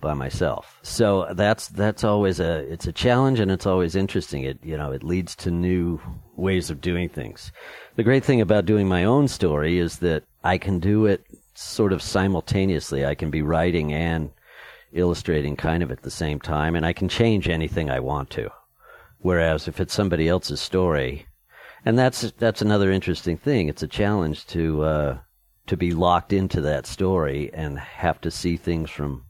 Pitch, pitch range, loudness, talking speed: 85 Hz, 75-95 Hz, -23 LUFS, 185 wpm